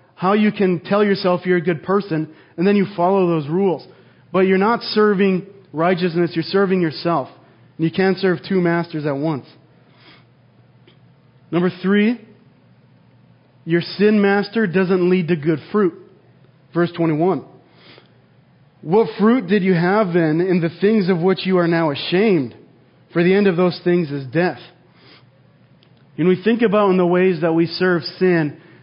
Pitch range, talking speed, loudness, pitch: 165-195 Hz, 160 wpm, -18 LUFS, 180 Hz